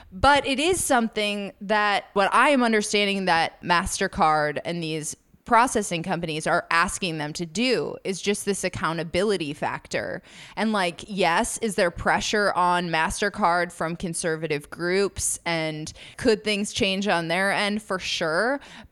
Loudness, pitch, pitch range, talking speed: -24 LUFS, 190 Hz, 170-210 Hz, 145 wpm